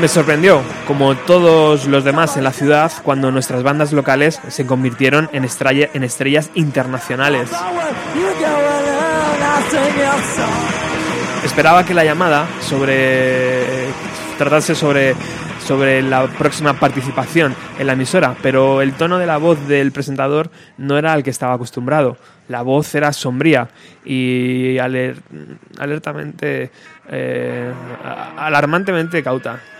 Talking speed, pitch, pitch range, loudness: 110 wpm, 140 Hz, 130-160 Hz, -15 LUFS